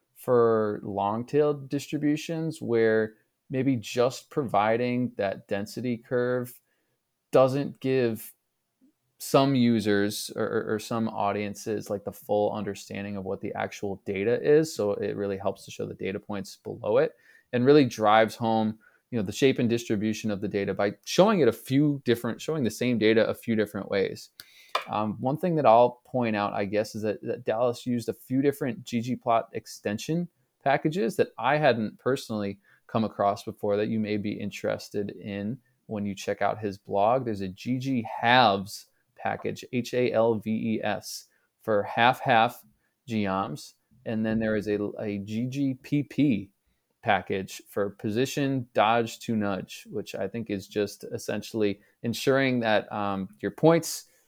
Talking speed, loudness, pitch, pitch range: 155 wpm, -27 LUFS, 110 Hz, 105-125 Hz